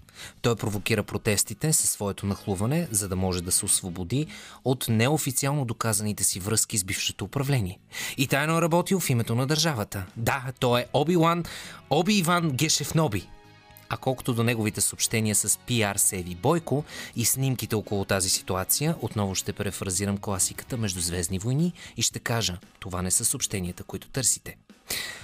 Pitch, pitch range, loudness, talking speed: 110 Hz, 100-135 Hz, -25 LUFS, 155 wpm